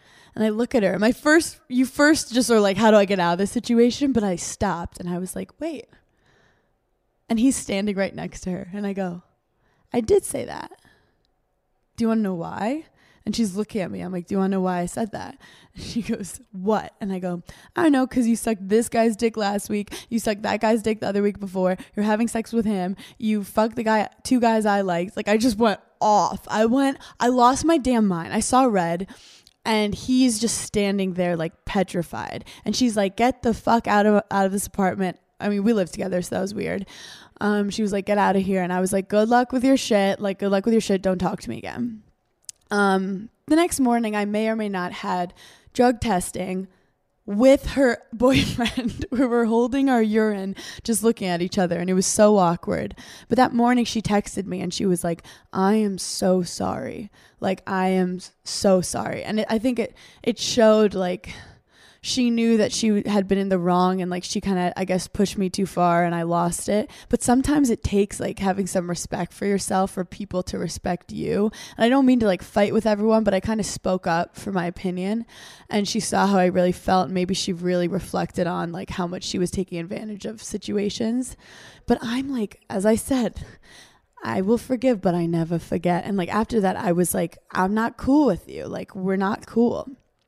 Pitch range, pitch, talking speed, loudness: 185-230 Hz, 205 Hz, 225 wpm, -22 LUFS